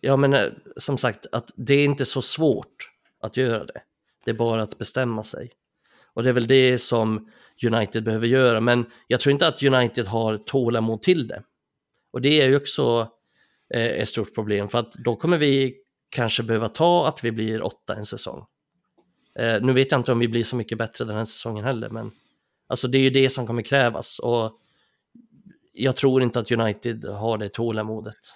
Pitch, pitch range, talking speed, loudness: 120 Hz, 115-135 Hz, 200 wpm, -22 LUFS